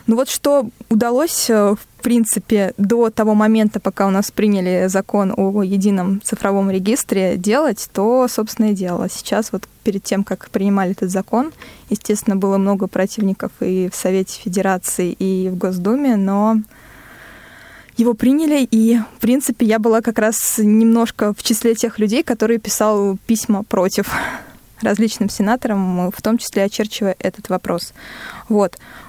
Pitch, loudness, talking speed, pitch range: 210 Hz, -17 LUFS, 145 wpm, 195-230 Hz